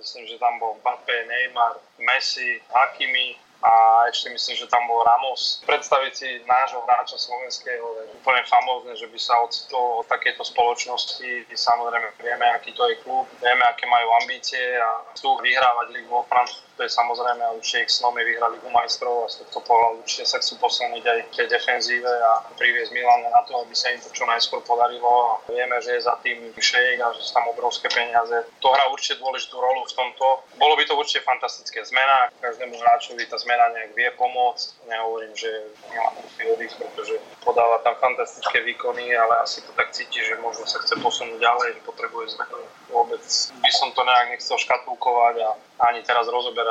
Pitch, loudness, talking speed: 120 Hz, -21 LUFS, 185 wpm